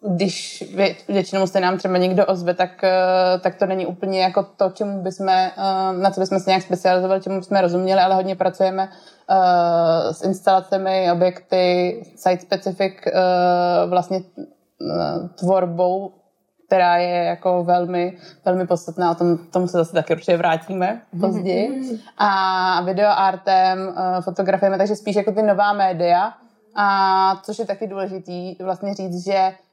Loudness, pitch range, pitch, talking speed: -19 LUFS, 180-195 Hz, 190 Hz, 135 wpm